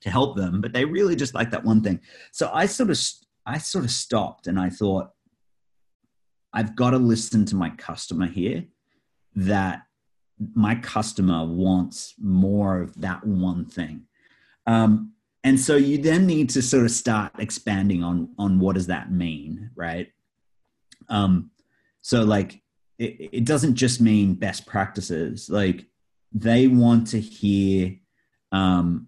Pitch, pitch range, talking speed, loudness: 105 Hz, 95-120 Hz, 150 wpm, -23 LUFS